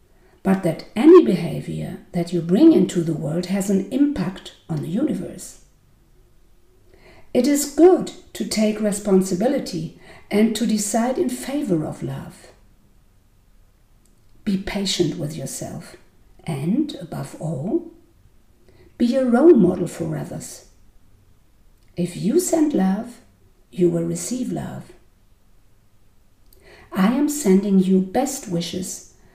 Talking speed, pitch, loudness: 115 wpm, 180 Hz, -20 LUFS